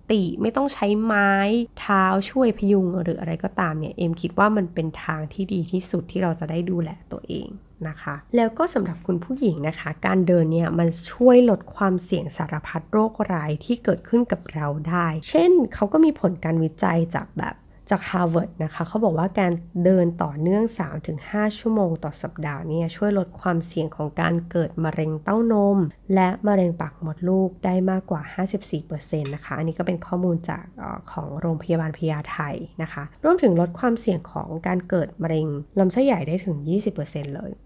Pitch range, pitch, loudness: 160-200 Hz, 180 Hz, -23 LUFS